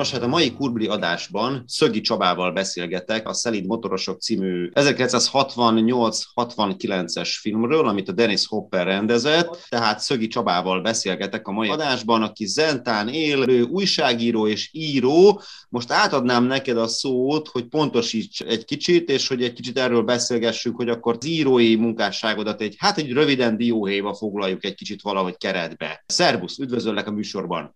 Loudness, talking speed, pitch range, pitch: -21 LUFS, 145 wpm, 105-130 Hz, 115 Hz